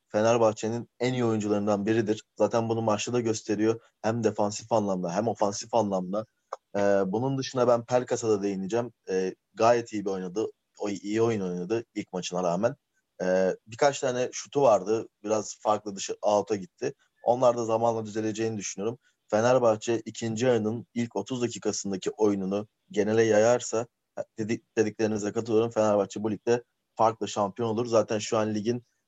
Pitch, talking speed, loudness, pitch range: 110 Hz, 150 wpm, -27 LUFS, 105-115 Hz